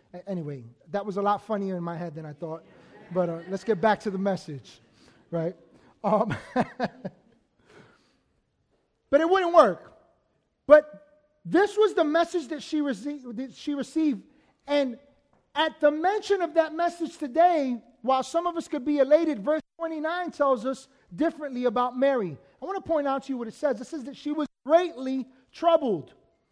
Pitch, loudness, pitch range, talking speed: 275 Hz, -26 LUFS, 205-315 Hz, 170 wpm